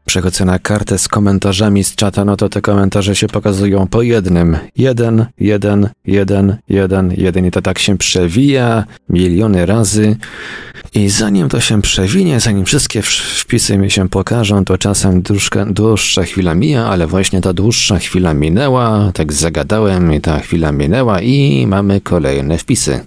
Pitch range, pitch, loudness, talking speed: 95-110 Hz, 100 Hz, -12 LUFS, 155 wpm